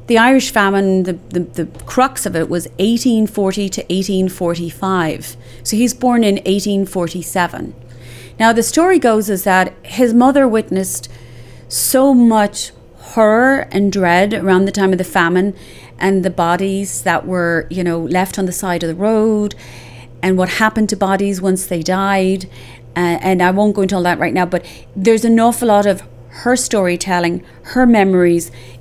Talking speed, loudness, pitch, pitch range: 165 wpm, -14 LUFS, 190 Hz, 175-215 Hz